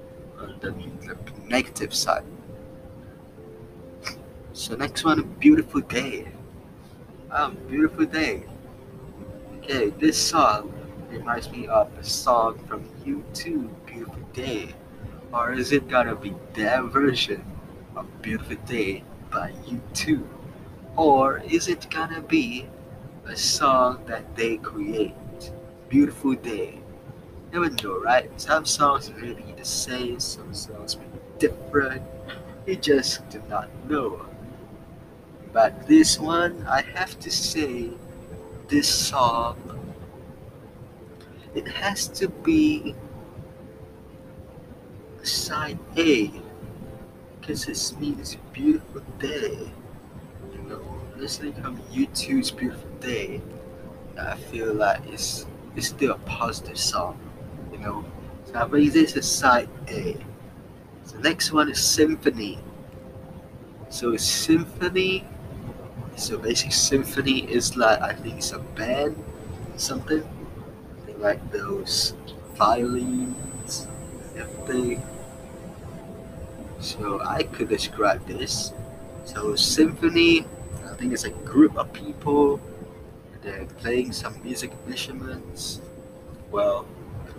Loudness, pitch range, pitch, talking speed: -24 LUFS, 120-195 Hz, 140 Hz, 110 wpm